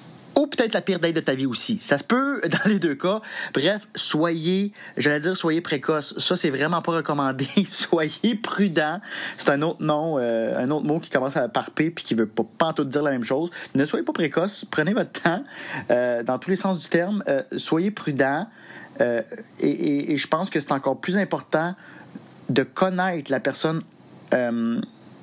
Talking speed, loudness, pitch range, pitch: 200 wpm, -23 LUFS, 150-195 Hz, 170 Hz